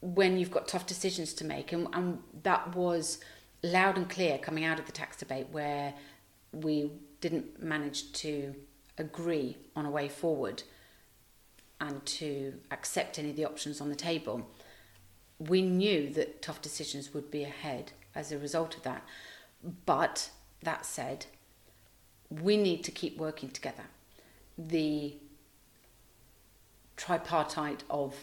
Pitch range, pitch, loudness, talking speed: 135-165 Hz, 150 Hz, -34 LUFS, 140 wpm